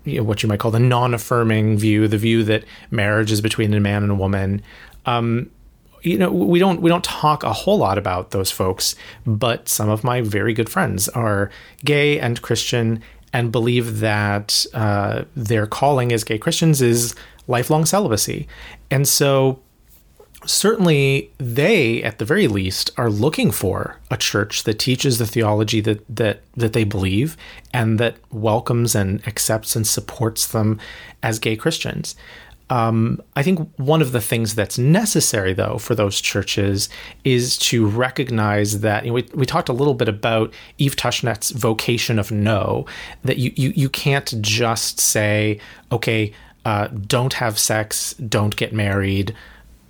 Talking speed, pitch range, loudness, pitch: 160 wpm, 105-130 Hz, -19 LUFS, 115 Hz